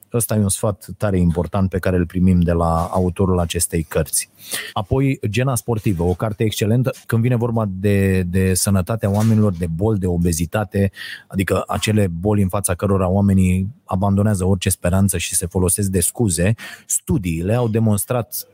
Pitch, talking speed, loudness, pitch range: 100 Hz, 160 wpm, -19 LUFS, 90-110 Hz